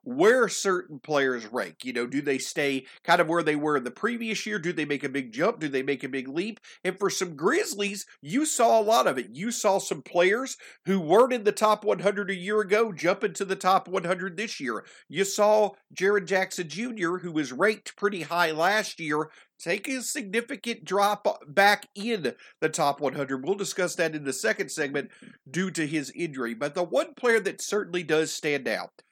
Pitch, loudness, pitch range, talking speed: 190 Hz, -26 LUFS, 155-215 Hz, 210 wpm